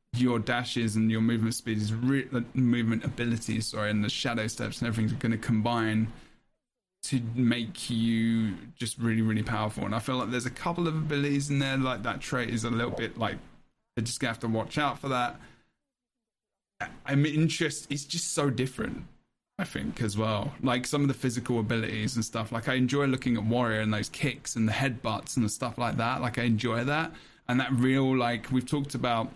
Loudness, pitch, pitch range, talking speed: -29 LUFS, 120 Hz, 115-135 Hz, 210 wpm